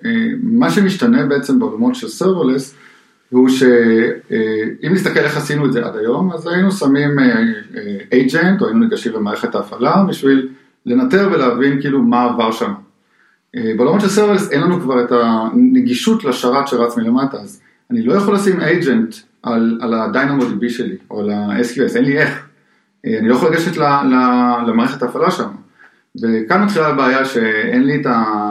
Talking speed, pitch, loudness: 160 wpm, 145 Hz, -15 LUFS